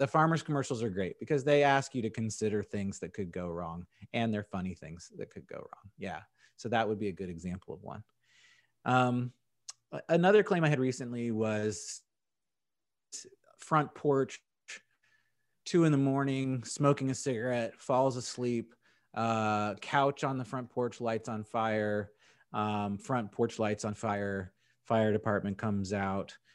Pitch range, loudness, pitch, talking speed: 105-135 Hz, -32 LUFS, 115 Hz, 160 wpm